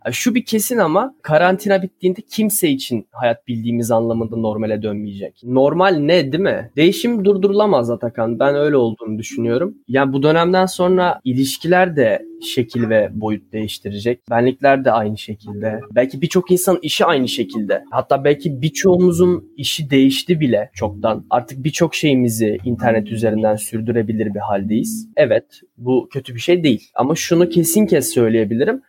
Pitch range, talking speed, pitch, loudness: 115-180 Hz, 145 wpm, 135 Hz, -17 LUFS